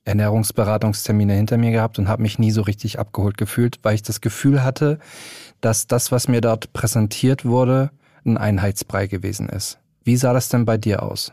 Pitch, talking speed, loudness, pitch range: 115 Hz, 185 wpm, -20 LUFS, 105-125 Hz